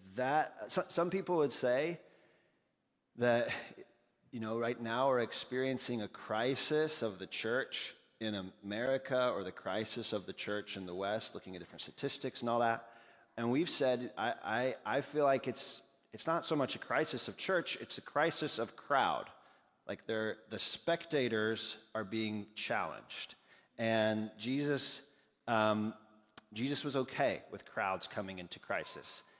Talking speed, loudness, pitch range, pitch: 155 wpm, -37 LUFS, 110-135 Hz, 115 Hz